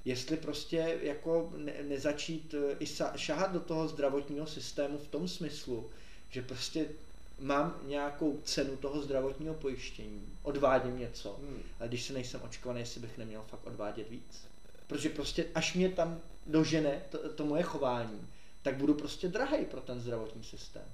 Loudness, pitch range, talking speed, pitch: -36 LUFS, 125-155 Hz, 150 wpm, 145 Hz